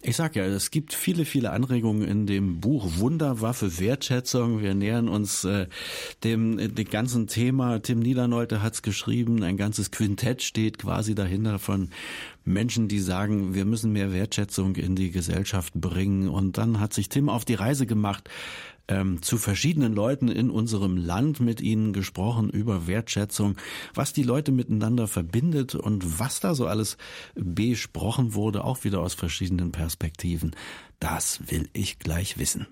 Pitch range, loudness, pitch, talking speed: 95-120 Hz, -26 LUFS, 105 Hz, 160 wpm